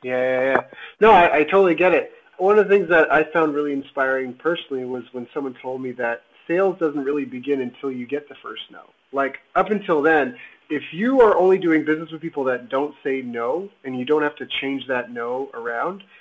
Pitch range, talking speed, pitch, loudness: 130-170 Hz, 220 wpm, 145 Hz, -20 LUFS